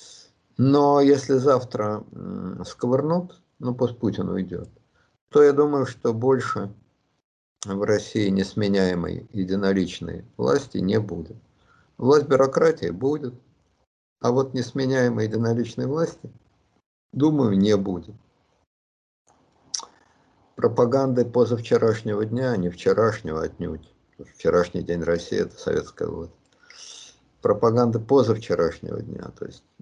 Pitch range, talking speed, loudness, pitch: 95-130 Hz, 100 wpm, -23 LUFS, 115 Hz